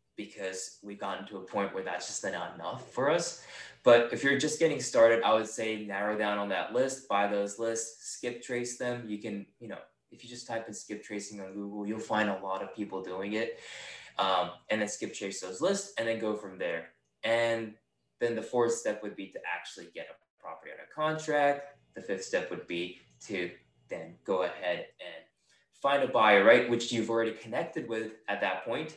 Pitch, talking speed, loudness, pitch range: 110 Hz, 215 wpm, -31 LUFS, 100-120 Hz